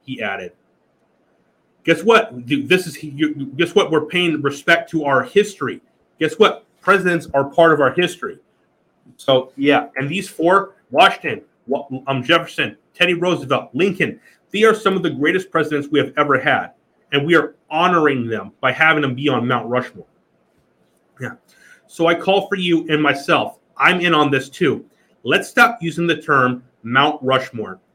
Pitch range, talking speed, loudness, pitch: 135-175 Hz, 165 wpm, -17 LUFS, 155 Hz